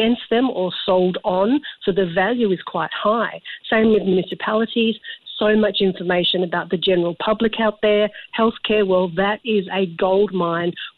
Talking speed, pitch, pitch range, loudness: 165 wpm, 205 Hz, 185-220 Hz, -19 LUFS